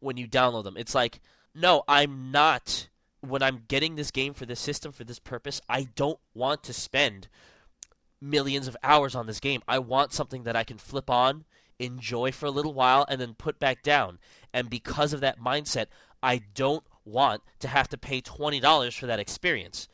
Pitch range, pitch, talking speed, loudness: 125-145 Hz, 130 Hz, 195 wpm, -27 LUFS